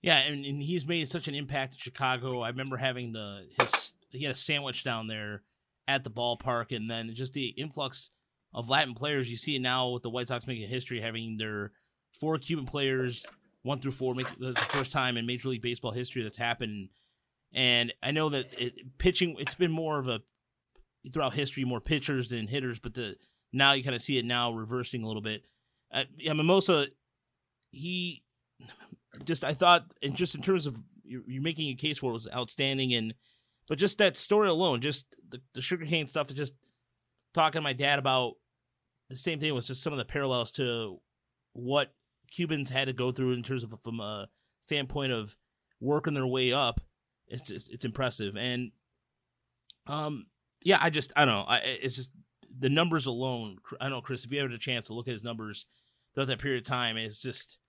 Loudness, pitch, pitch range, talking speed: -30 LUFS, 130 Hz, 120-145 Hz, 200 wpm